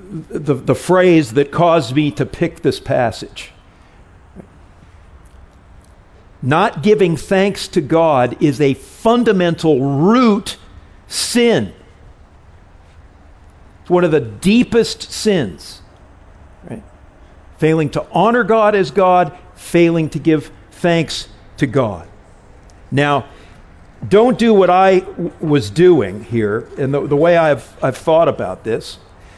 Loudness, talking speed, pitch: -15 LUFS, 115 wpm, 145 Hz